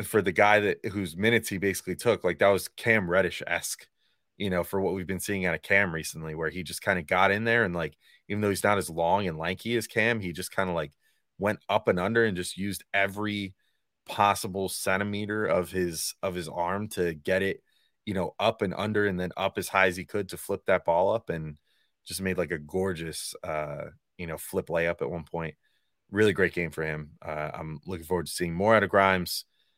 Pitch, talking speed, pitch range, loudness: 95 Hz, 235 wpm, 85-100 Hz, -28 LUFS